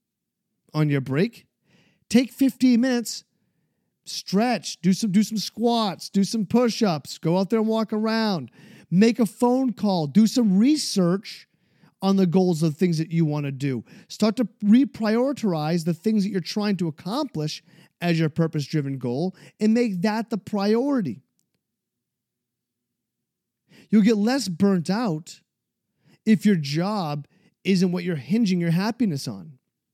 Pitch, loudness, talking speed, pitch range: 195 Hz, -23 LUFS, 150 wpm, 170-225 Hz